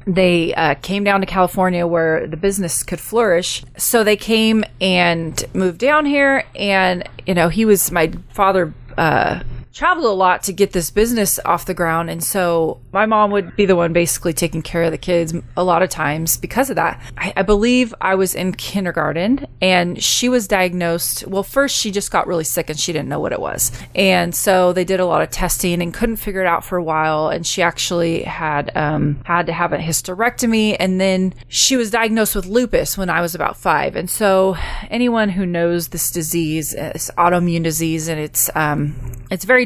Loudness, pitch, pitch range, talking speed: -17 LUFS, 180 Hz, 165-200 Hz, 205 wpm